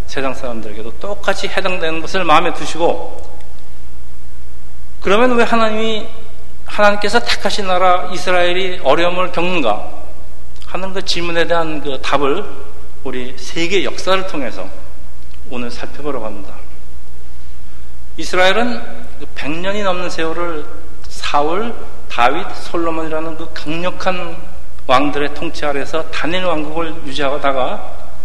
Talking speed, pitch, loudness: 270 characters per minute, 160 Hz, -18 LUFS